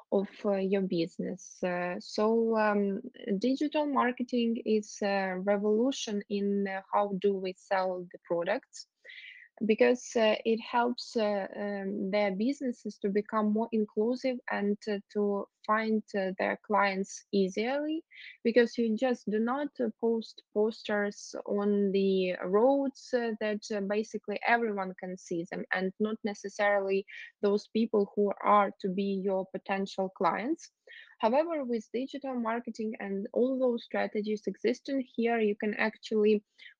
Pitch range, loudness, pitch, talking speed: 200-235 Hz, -31 LUFS, 215 Hz, 135 wpm